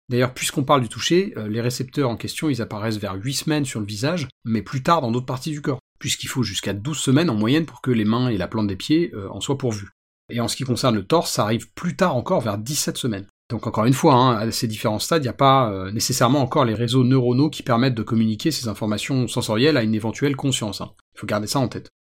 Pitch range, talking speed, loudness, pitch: 110-145 Hz, 265 wpm, -21 LUFS, 125 Hz